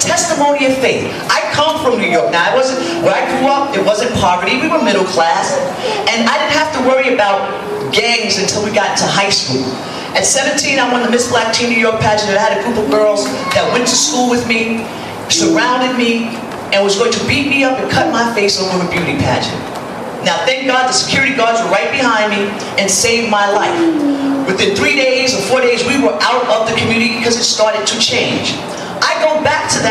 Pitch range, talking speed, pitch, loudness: 210-265 Hz, 215 wpm, 235 Hz, -13 LUFS